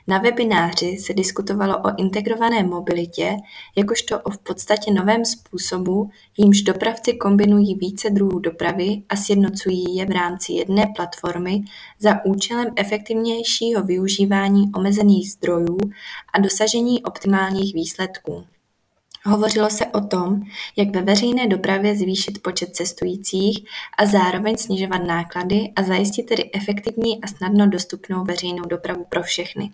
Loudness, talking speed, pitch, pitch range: -18 LUFS, 125 wpm, 200 Hz, 180-210 Hz